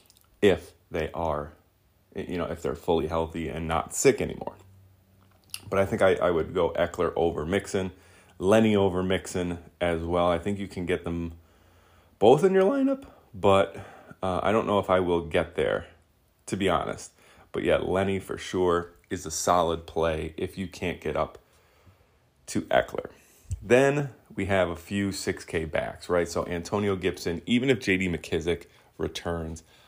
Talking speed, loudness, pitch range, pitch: 165 wpm, -27 LUFS, 85-95 Hz, 90 Hz